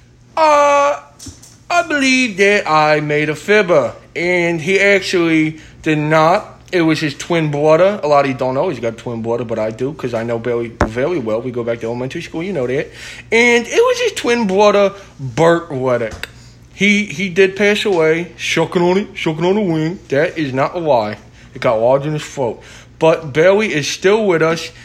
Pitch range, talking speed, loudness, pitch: 140-200 Hz, 205 wpm, -15 LUFS, 165 Hz